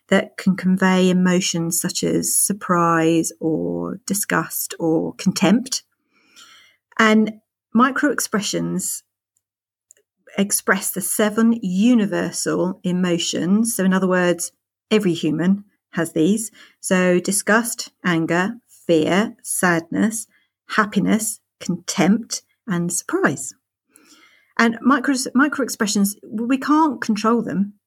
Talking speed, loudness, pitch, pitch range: 90 wpm, -19 LUFS, 195 Hz, 175-225 Hz